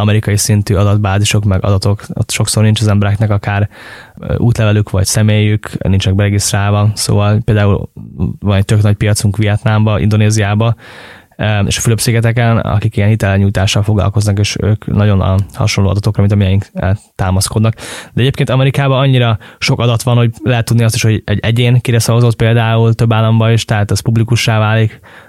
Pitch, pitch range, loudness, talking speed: 105 Hz, 100-115 Hz, -12 LUFS, 155 wpm